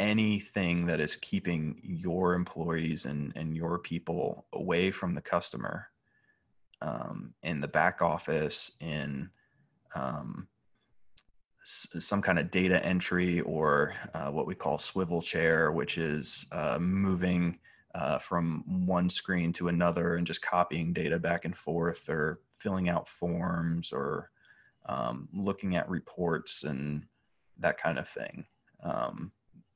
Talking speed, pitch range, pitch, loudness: 135 wpm, 80-95 Hz, 85 Hz, -32 LUFS